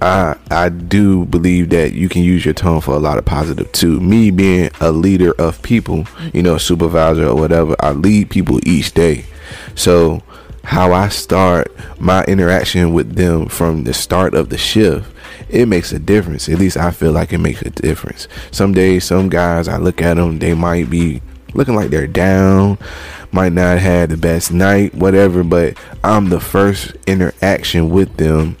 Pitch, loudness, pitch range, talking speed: 90 Hz, -13 LUFS, 80-95 Hz, 185 wpm